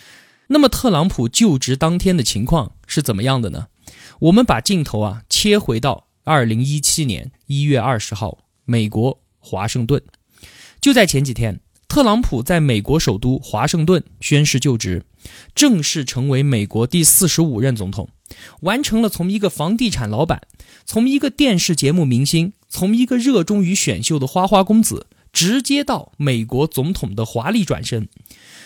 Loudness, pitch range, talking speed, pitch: -17 LUFS, 120-190 Hz, 250 characters per minute, 145 Hz